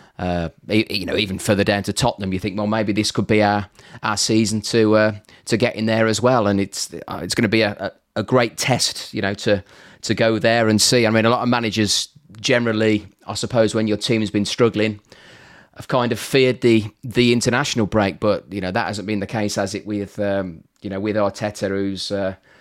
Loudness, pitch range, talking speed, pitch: -19 LUFS, 100-115 Hz, 225 wpm, 105 Hz